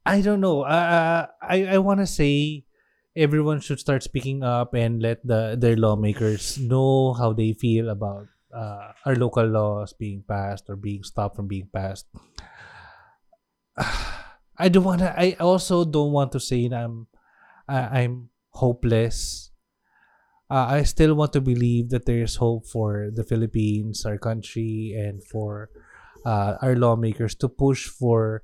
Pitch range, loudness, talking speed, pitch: 110-140 Hz, -23 LUFS, 155 wpm, 115 Hz